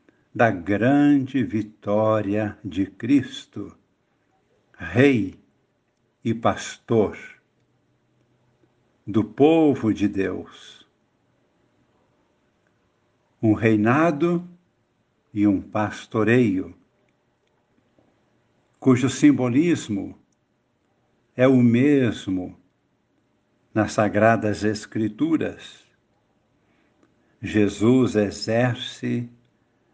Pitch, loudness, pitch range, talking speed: 115 Hz, -21 LUFS, 105-125 Hz, 55 wpm